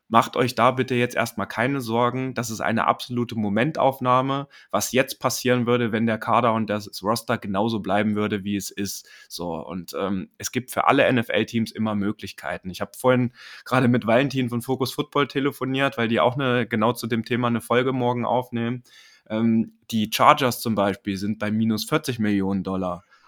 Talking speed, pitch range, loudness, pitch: 185 wpm, 105-125 Hz, -23 LUFS, 115 Hz